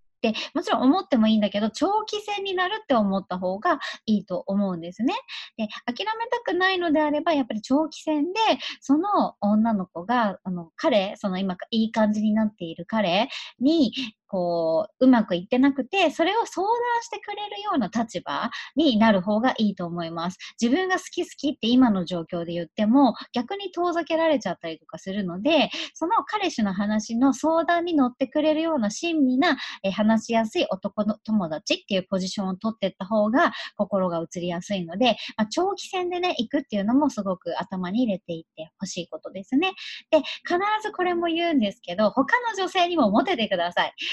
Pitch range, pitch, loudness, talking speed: 200-325 Hz, 245 Hz, -24 LUFS, 375 characters per minute